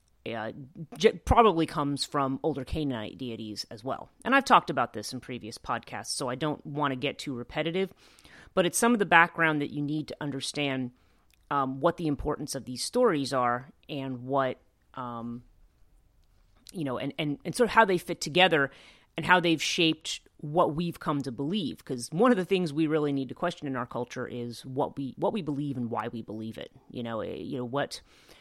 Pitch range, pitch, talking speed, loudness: 125-165 Hz, 145 Hz, 205 wpm, -28 LUFS